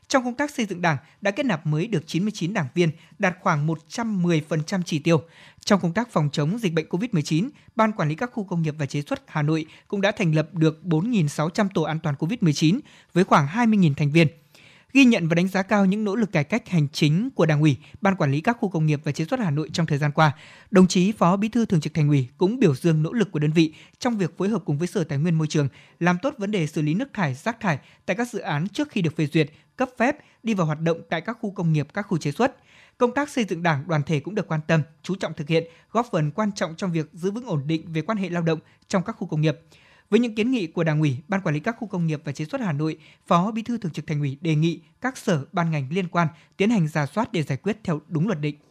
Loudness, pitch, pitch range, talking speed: -24 LUFS, 170 Hz, 155-205 Hz, 280 wpm